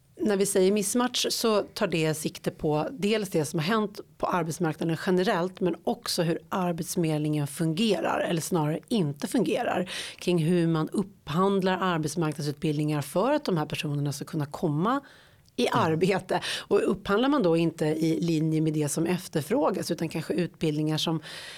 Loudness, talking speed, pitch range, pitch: -27 LUFS, 155 wpm, 155-190 Hz, 170 Hz